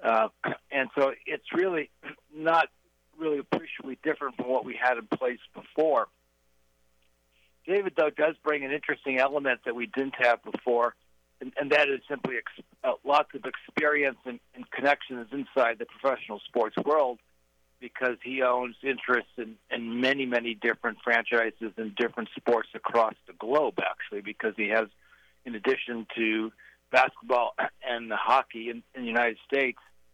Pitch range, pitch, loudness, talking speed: 110-135 Hz, 120 Hz, -28 LUFS, 155 wpm